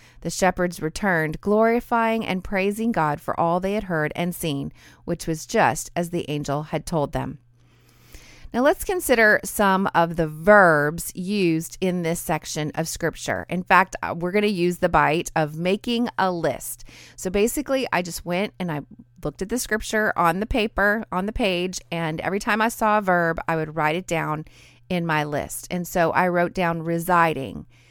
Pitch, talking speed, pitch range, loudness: 175 Hz, 185 wpm, 155-200 Hz, -22 LUFS